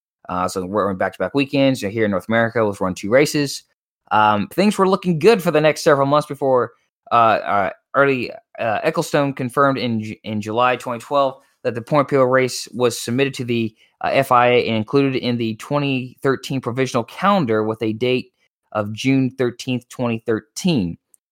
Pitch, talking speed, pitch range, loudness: 125 Hz, 175 wpm, 115-140 Hz, -19 LUFS